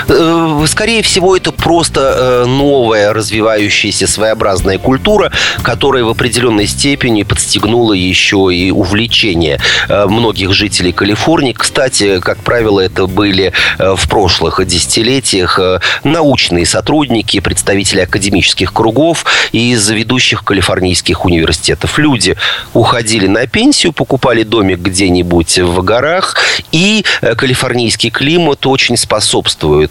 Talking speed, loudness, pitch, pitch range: 100 wpm, -9 LUFS, 110 Hz, 95-130 Hz